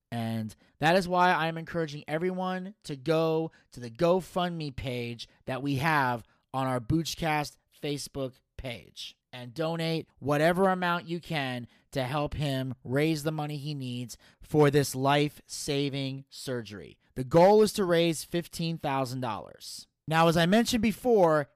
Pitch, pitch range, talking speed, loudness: 150 Hz, 130-165 Hz, 140 wpm, -28 LUFS